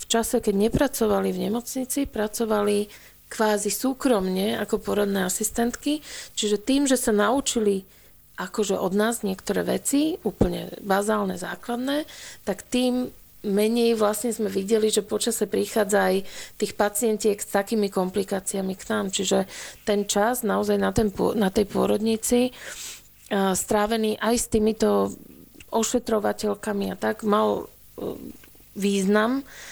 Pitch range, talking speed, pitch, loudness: 200-230 Hz, 120 wpm, 210 Hz, -24 LUFS